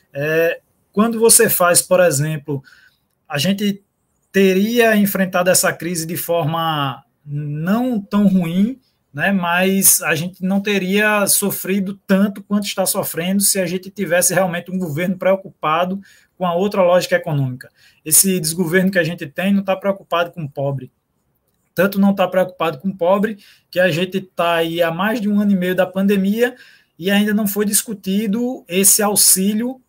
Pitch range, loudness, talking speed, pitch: 170-200 Hz, -16 LUFS, 165 wpm, 190 Hz